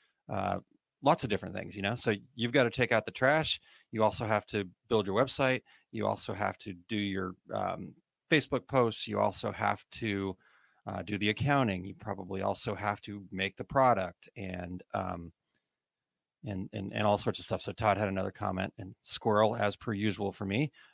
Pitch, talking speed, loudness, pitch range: 105 Hz, 195 wpm, -32 LUFS, 95-115 Hz